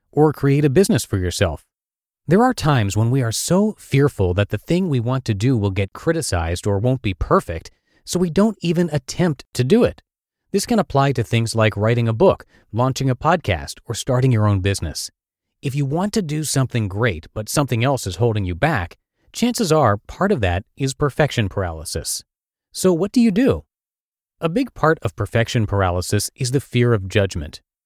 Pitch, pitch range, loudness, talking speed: 125 Hz, 100-155 Hz, -19 LUFS, 195 wpm